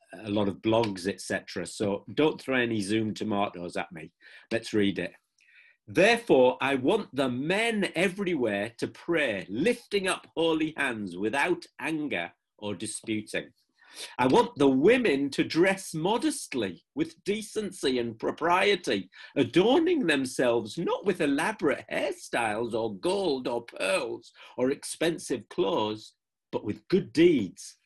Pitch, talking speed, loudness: 135 Hz, 130 wpm, -28 LUFS